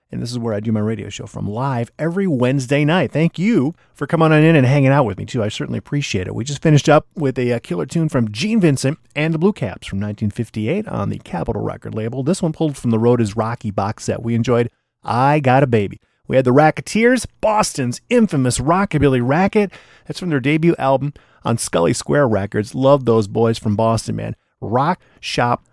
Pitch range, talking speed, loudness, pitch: 115-155 Hz, 215 wpm, -18 LUFS, 135 Hz